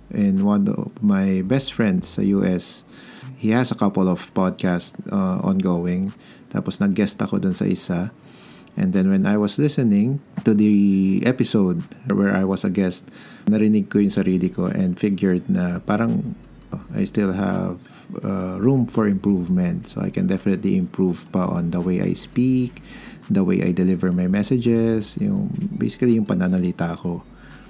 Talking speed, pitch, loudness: 160 wpm, 110 Hz, -21 LUFS